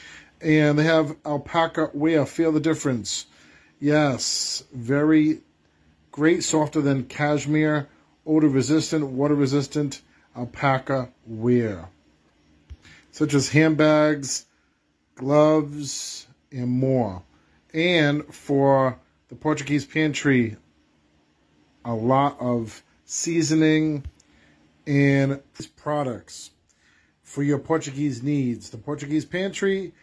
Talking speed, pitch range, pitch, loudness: 90 wpm, 120-155 Hz, 140 Hz, -23 LUFS